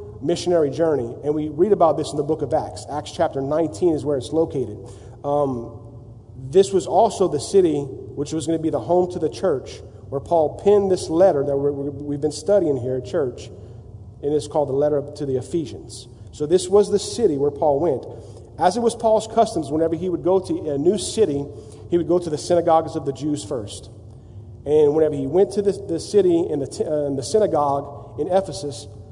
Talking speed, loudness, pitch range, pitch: 210 wpm, -21 LUFS, 130-170 Hz, 150 Hz